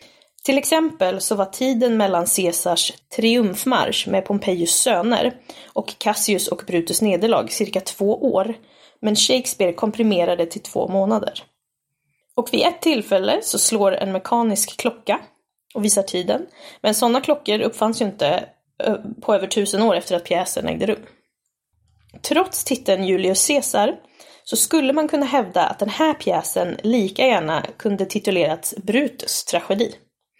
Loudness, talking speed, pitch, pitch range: -20 LUFS, 140 wpm, 215 Hz, 195-260 Hz